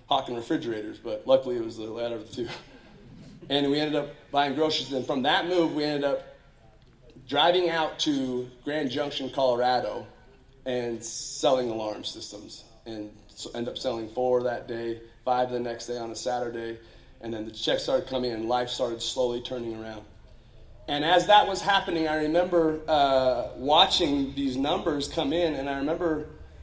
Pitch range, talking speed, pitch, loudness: 115-150 Hz, 175 wpm, 130 Hz, -27 LUFS